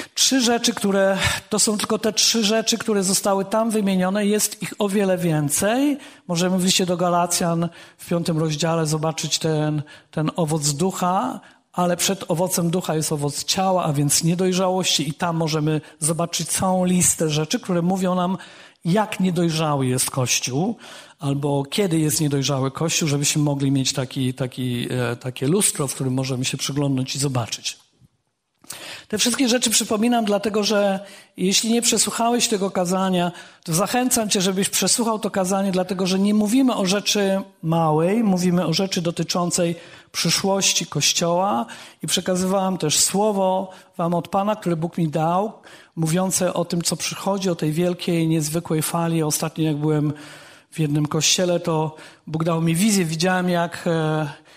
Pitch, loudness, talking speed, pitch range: 175 Hz, -21 LUFS, 155 wpm, 155-195 Hz